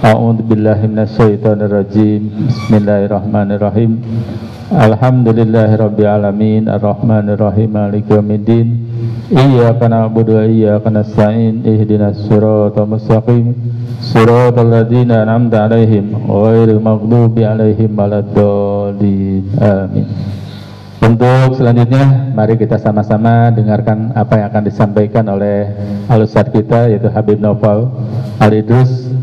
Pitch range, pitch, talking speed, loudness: 105-115 Hz, 110 Hz, 90 wpm, -11 LUFS